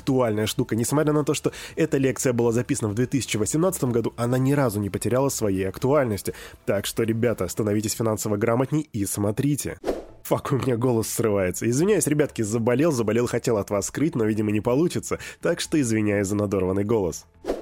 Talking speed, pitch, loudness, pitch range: 175 wpm, 120 Hz, -24 LUFS, 105-135 Hz